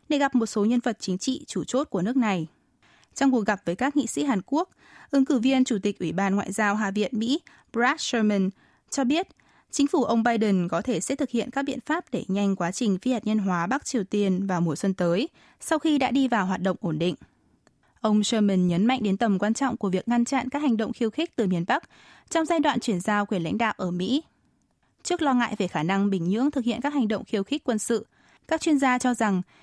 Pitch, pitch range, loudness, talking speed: 230 Hz, 195-270 Hz, -25 LUFS, 255 wpm